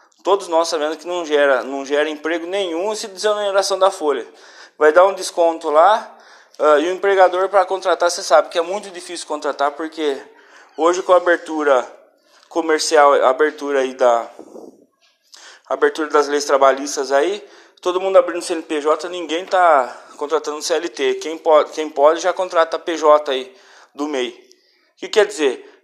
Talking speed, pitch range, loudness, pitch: 165 wpm, 150-195 Hz, -17 LUFS, 170 Hz